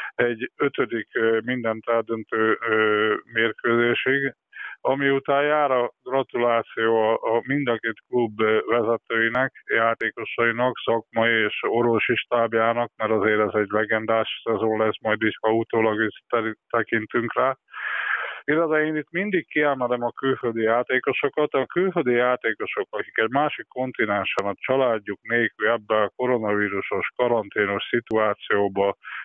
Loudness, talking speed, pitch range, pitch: -23 LUFS, 120 wpm, 110-125 Hz, 115 Hz